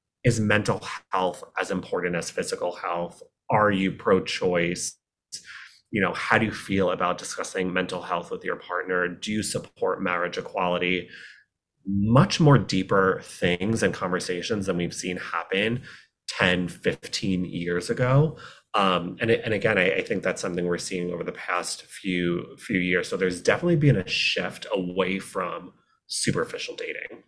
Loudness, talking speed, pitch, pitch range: -25 LUFS, 155 wpm, 95 Hz, 90-125 Hz